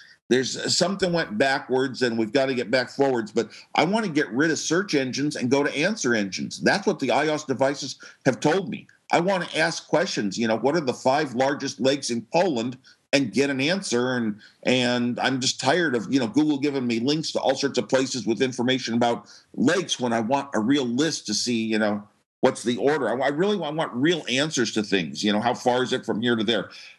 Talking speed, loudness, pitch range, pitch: 235 wpm, -24 LUFS, 115-140 Hz, 130 Hz